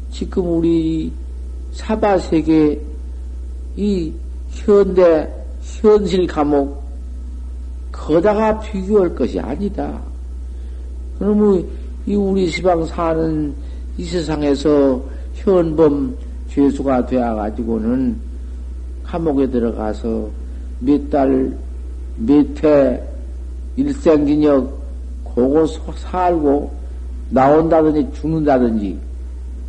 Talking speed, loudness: 165 characters per minute, -17 LUFS